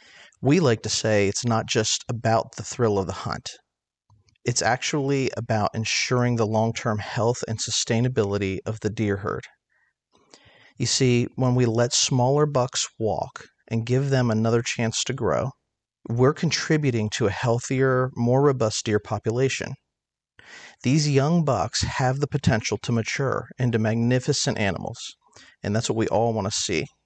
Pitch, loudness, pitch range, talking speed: 120 Hz, -23 LUFS, 110-130 Hz, 155 wpm